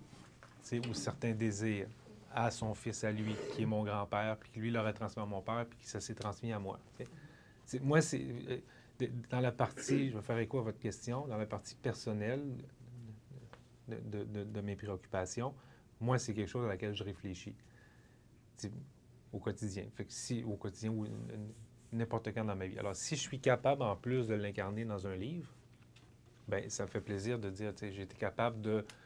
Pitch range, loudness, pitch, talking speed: 105-120 Hz, -39 LUFS, 110 Hz, 200 wpm